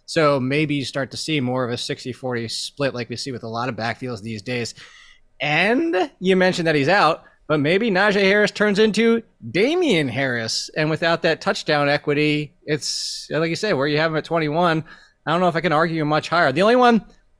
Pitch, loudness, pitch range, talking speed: 155 Hz, -20 LUFS, 135-185 Hz, 215 wpm